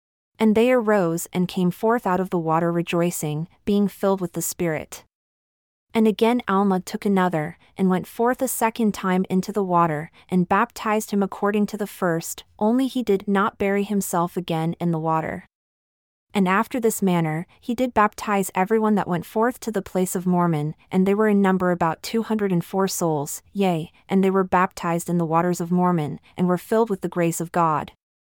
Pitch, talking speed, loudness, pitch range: 185 Hz, 195 wpm, -22 LUFS, 170-210 Hz